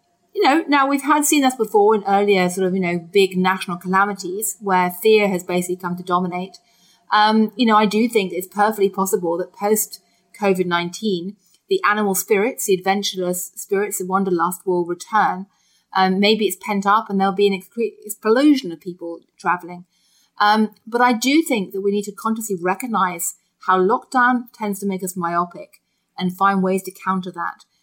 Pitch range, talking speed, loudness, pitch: 185-215 Hz, 180 wpm, -19 LUFS, 195 Hz